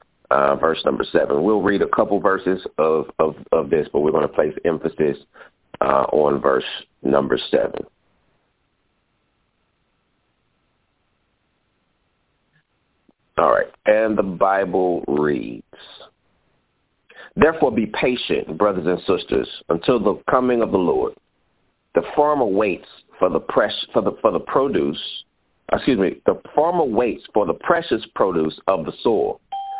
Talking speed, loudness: 130 wpm, -20 LUFS